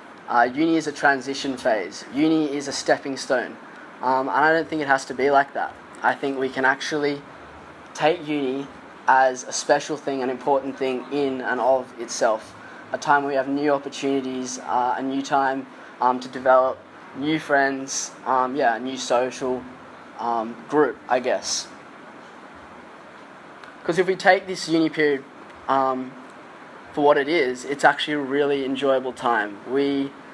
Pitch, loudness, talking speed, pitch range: 135 Hz, -23 LUFS, 165 wpm, 130-145 Hz